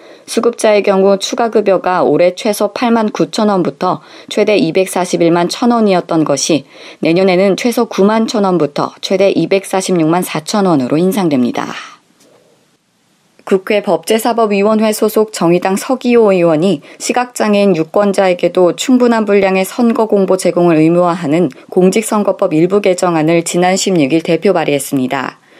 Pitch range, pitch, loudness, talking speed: 175-215 Hz, 190 Hz, -12 LUFS, 280 characters per minute